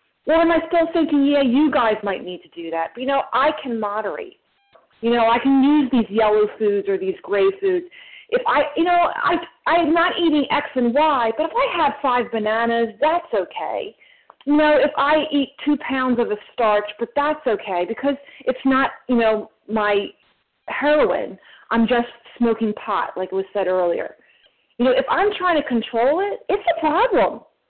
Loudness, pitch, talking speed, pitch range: -20 LUFS, 270 Hz, 195 wpm, 225-315 Hz